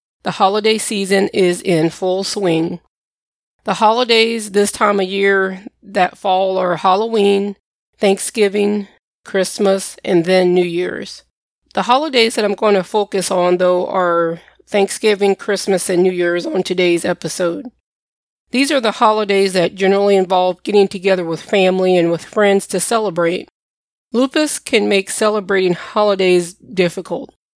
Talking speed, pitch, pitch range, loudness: 135 wpm, 195 Hz, 180-210 Hz, -15 LUFS